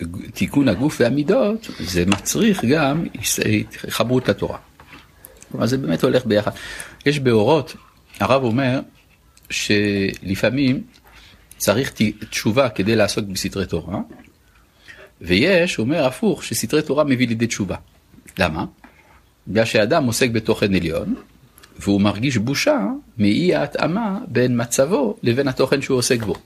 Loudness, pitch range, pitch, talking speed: -19 LUFS, 100-135 Hz, 115 Hz, 115 wpm